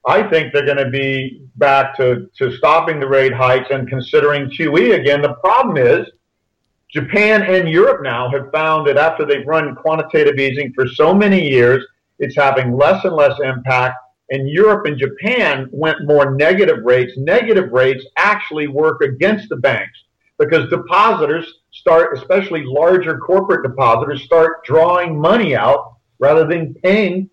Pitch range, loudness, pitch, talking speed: 135-165 Hz, -14 LUFS, 145 Hz, 155 wpm